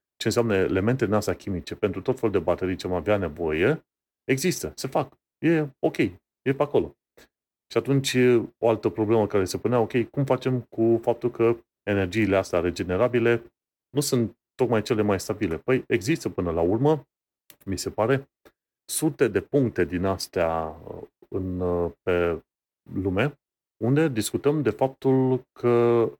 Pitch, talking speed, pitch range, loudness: 115 Hz, 150 wpm, 95-130 Hz, -25 LUFS